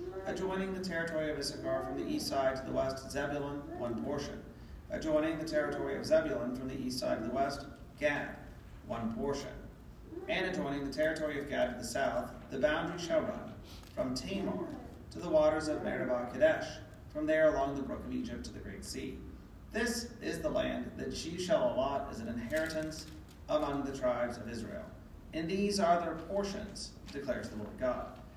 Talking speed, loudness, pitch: 185 wpm, -35 LUFS, 165 Hz